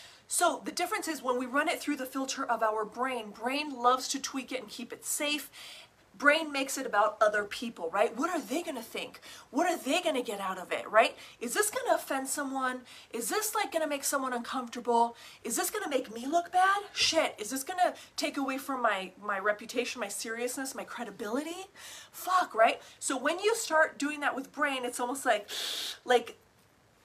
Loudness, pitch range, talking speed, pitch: -31 LUFS, 235-320 Hz, 215 wpm, 270 Hz